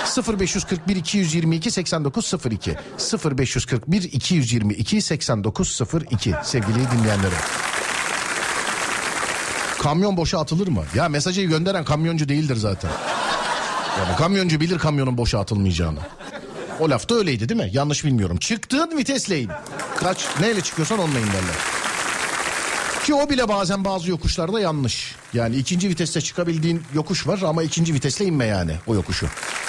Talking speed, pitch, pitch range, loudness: 110 wpm, 155 Hz, 120-185 Hz, -22 LUFS